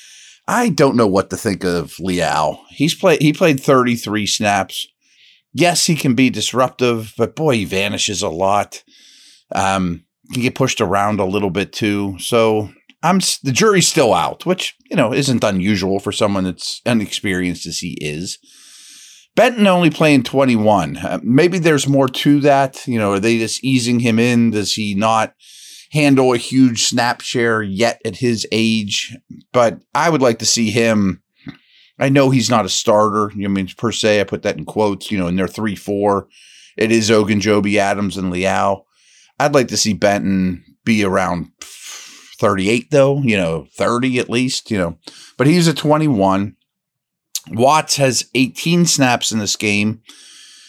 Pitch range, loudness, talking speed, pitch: 100-135 Hz, -16 LUFS, 170 wpm, 110 Hz